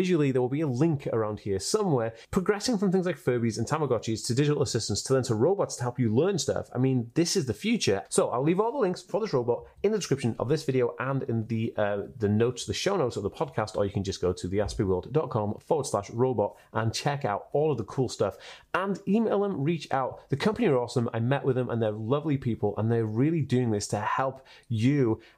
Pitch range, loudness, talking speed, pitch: 110-150 Hz, -28 LUFS, 245 wpm, 125 Hz